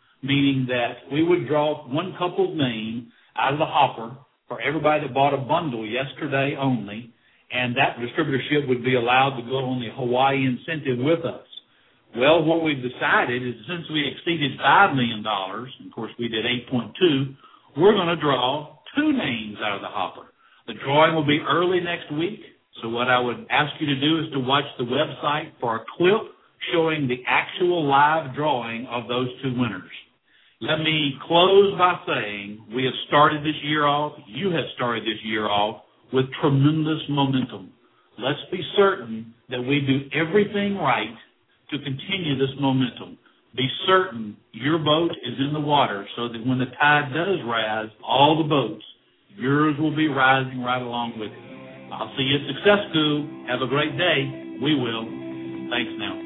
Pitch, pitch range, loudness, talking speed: 135 Hz, 120-155 Hz, -22 LUFS, 175 wpm